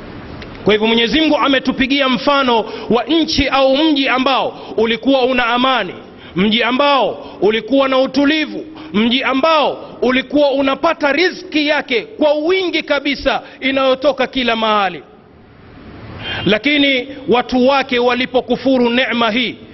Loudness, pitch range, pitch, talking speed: -14 LUFS, 245-285 Hz, 265 Hz, 110 wpm